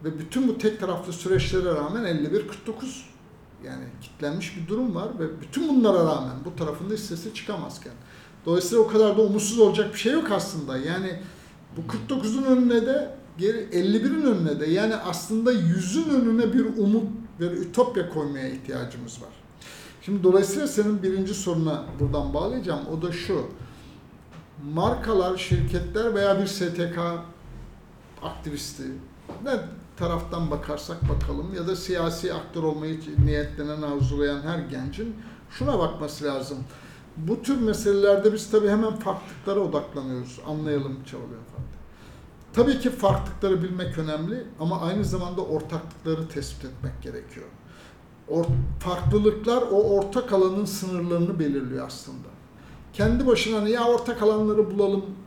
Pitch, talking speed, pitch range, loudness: 180 Hz, 130 wpm, 155-215 Hz, -25 LUFS